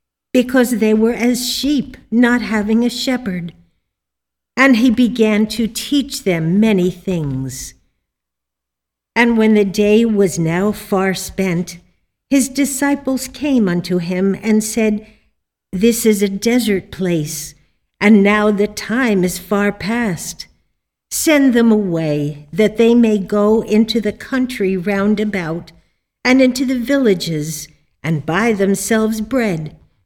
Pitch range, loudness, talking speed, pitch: 175-235 Hz, -16 LUFS, 130 wpm, 210 Hz